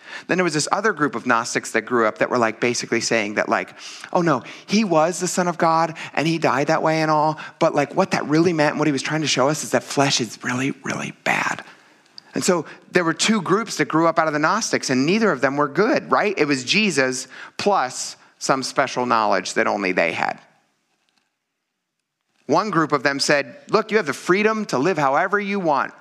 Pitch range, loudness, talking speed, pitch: 135-180 Hz, -20 LUFS, 230 wpm, 155 Hz